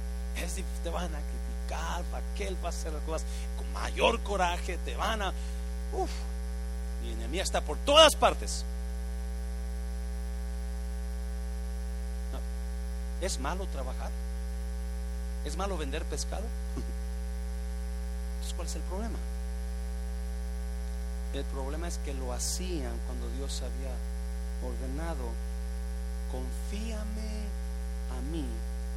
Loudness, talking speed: -34 LUFS, 105 wpm